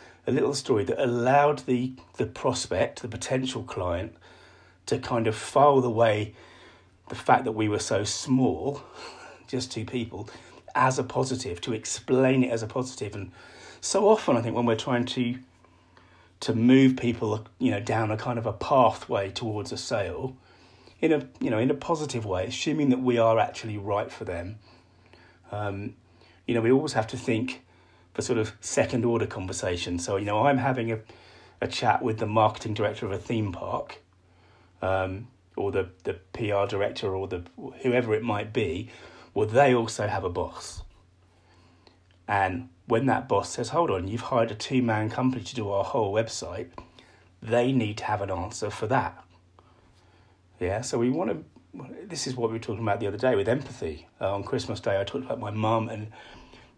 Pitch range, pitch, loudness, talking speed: 95-125 Hz, 110 Hz, -27 LUFS, 185 wpm